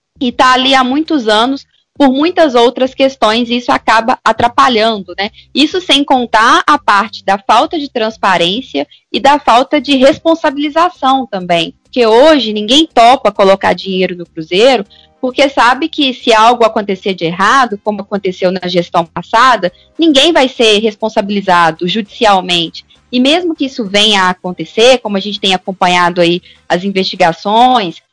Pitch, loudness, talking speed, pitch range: 225 Hz, -10 LUFS, 150 wpm, 190-265 Hz